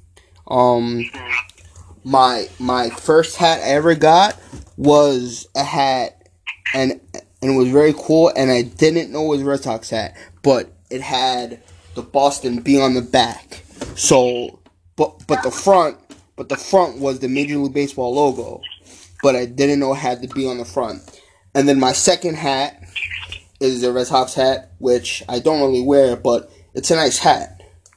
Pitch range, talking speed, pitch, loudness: 120-140 Hz, 175 wpm, 130 Hz, -17 LUFS